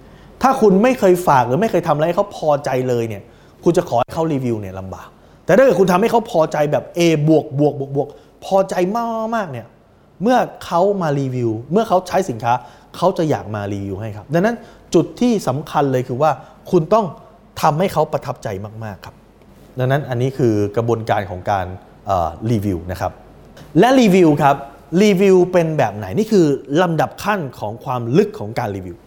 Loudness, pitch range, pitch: -17 LUFS, 115-185 Hz, 150 Hz